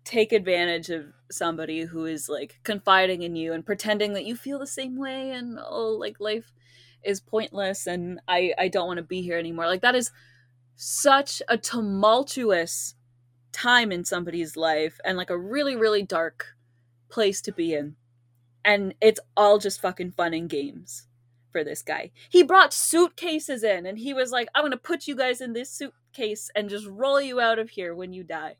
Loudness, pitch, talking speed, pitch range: -25 LUFS, 195 Hz, 190 wpm, 165-235 Hz